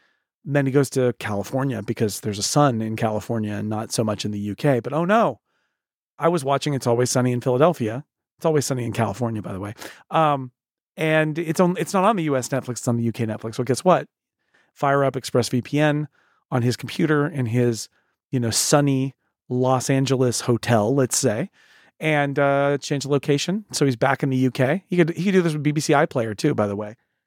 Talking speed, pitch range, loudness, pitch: 210 wpm, 120-150 Hz, -22 LUFS, 135 Hz